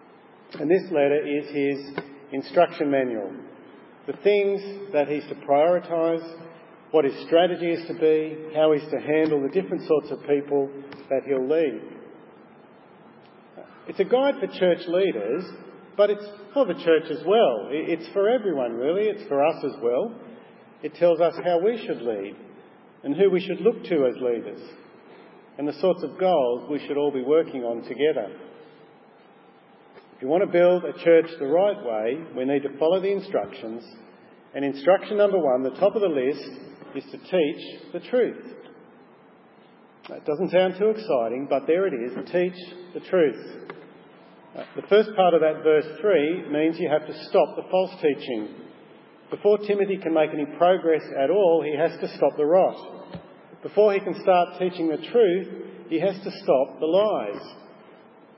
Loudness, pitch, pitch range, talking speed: -23 LUFS, 170 Hz, 150-195 Hz, 170 wpm